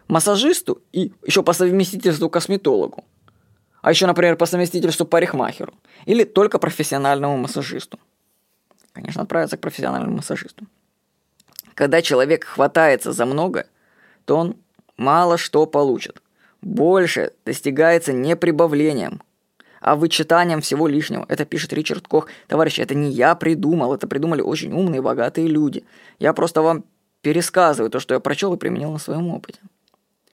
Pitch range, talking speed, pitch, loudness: 150-180 Hz, 135 wpm, 165 Hz, -19 LUFS